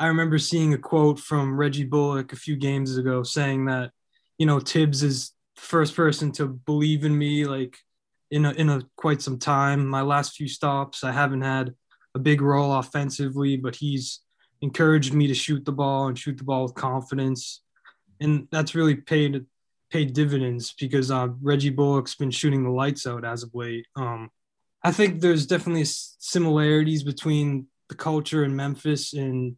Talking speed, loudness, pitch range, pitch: 180 wpm, -24 LUFS, 135-150 Hz, 140 Hz